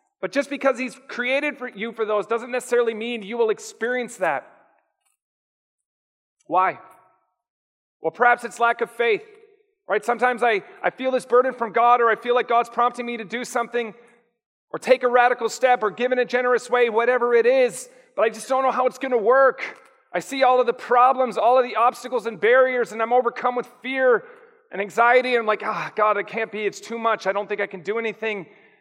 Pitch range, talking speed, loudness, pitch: 225-255 Hz, 210 wpm, -21 LUFS, 240 Hz